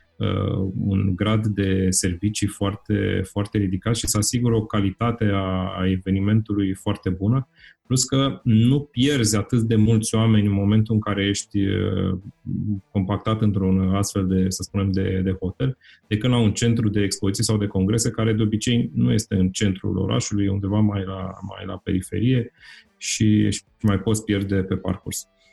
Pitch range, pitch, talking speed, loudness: 95-110 Hz, 100 Hz, 160 wpm, -22 LUFS